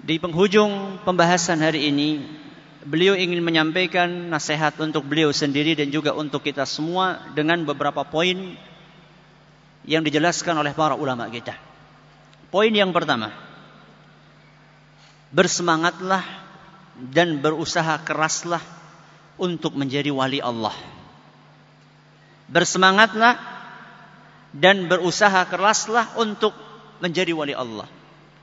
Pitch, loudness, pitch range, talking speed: 165 Hz, -21 LUFS, 150-185 Hz, 95 wpm